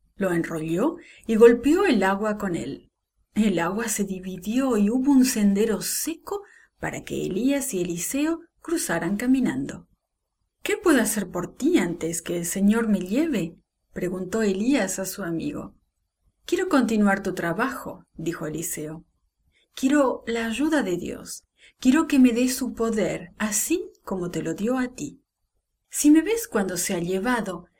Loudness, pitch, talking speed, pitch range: -24 LUFS, 220 Hz, 155 wpm, 185-275 Hz